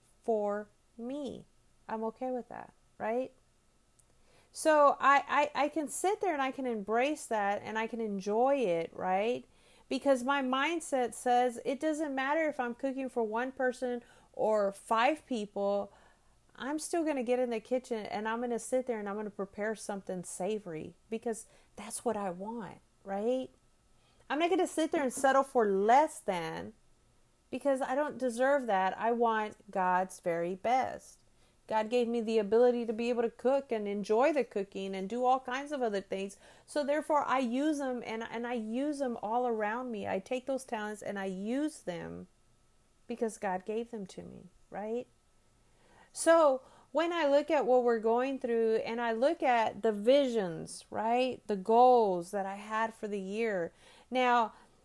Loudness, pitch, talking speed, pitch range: -32 LUFS, 235 Hz, 175 wpm, 210-265 Hz